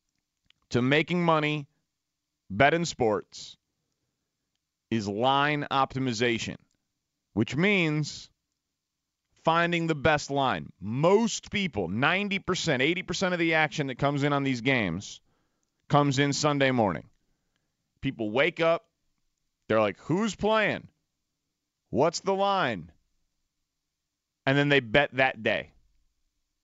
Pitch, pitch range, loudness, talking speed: 145 Hz, 125-165 Hz, -26 LUFS, 105 wpm